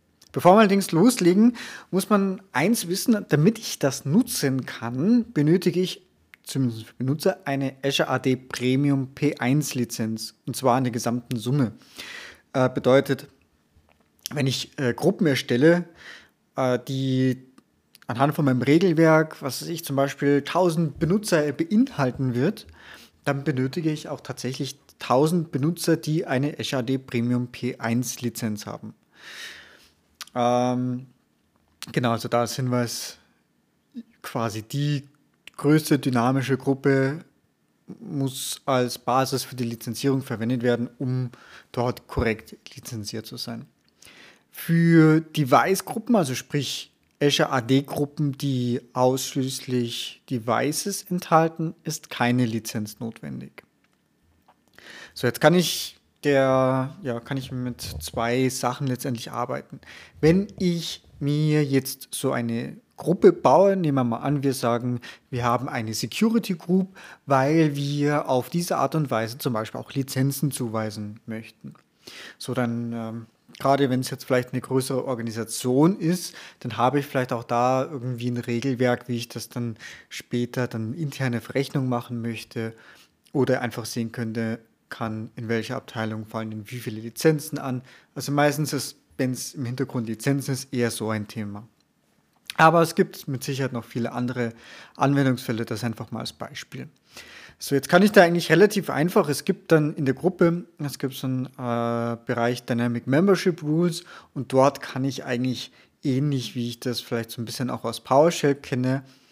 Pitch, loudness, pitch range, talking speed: 130 Hz, -24 LUFS, 120-150 Hz, 140 wpm